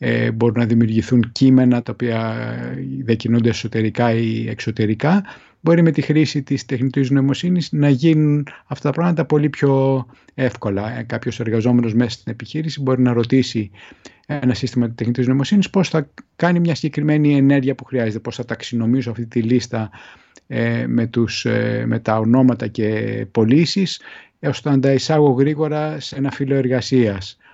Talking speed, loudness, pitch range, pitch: 150 wpm, -18 LUFS, 115-145 Hz, 125 Hz